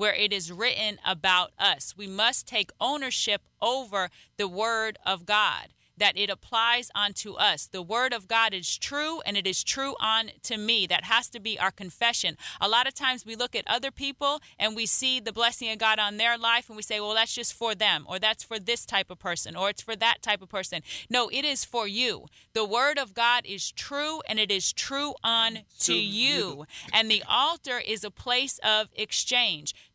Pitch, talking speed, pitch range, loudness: 220 Hz, 210 wpm, 200-245 Hz, -26 LUFS